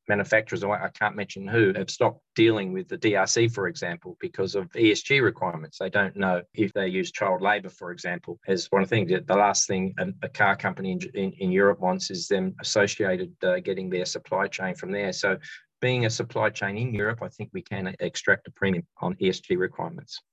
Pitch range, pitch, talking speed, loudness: 95-105 Hz, 100 Hz, 200 wpm, -26 LUFS